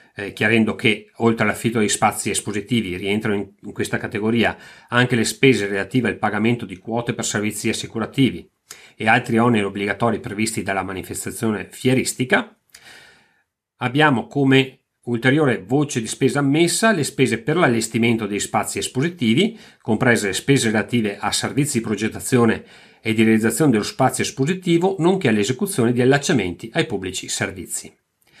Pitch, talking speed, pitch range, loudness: 115 Hz, 140 wpm, 105-130 Hz, -20 LUFS